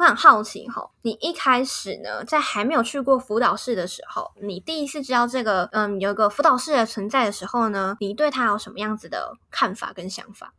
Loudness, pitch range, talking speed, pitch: -22 LUFS, 205-265 Hz, 325 characters per minute, 230 Hz